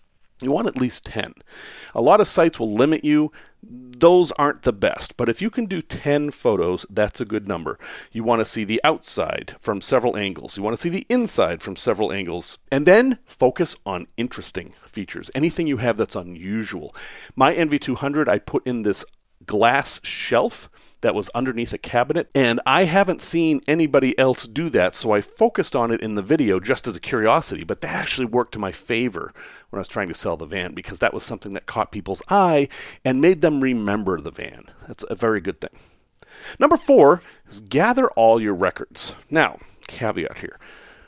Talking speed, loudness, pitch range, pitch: 195 wpm, -21 LUFS, 110-160 Hz, 130 Hz